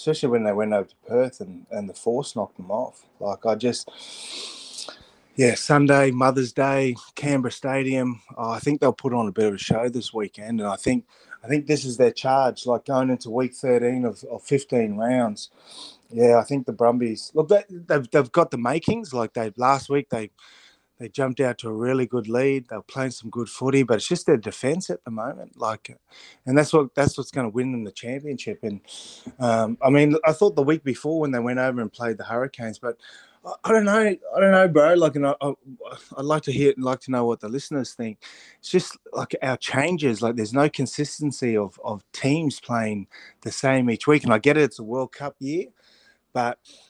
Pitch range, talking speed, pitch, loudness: 120-145 Hz, 220 wpm, 130 Hz, -23 LUFS